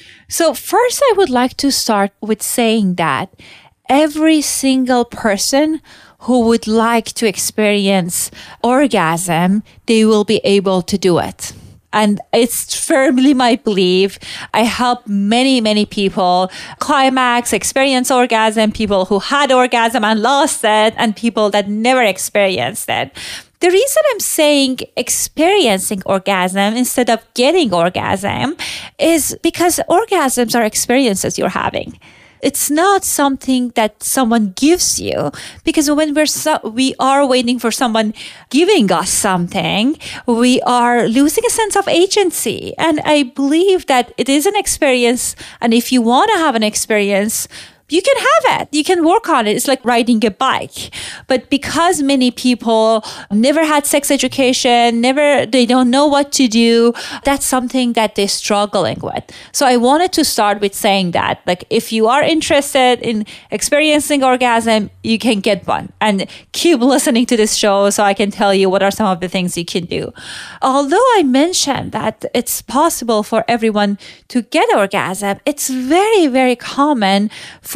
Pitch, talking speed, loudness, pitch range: 245 Hz, 155 wpm, -14 LUFS, 215-285 Hz